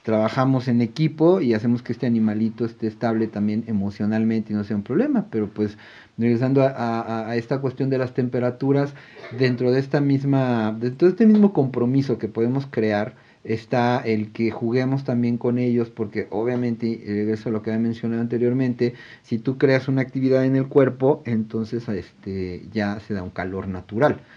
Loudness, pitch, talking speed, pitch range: -22 LUFS, 120 Hz, 180 wpm, 110-130 Hz